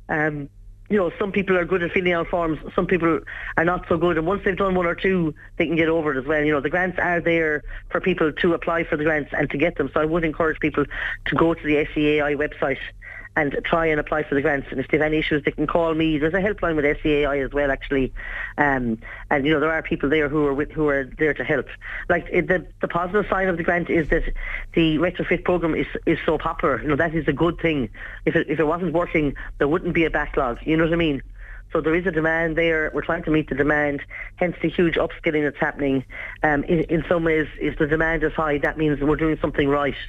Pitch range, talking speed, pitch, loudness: 150-170 Hz, 260 wpm, 160 Hz, -22 LUFS